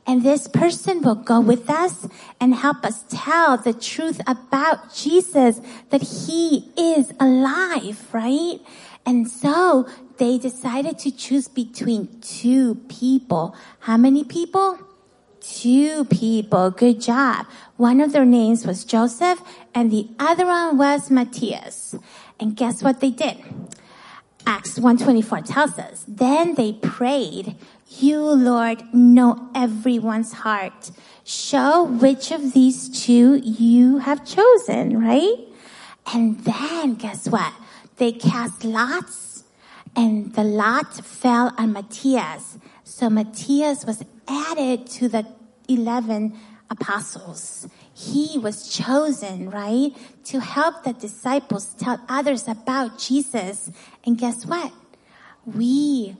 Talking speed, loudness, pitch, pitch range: 120 wpm, -19 LUFS, 245 Hz, 225-280 Hz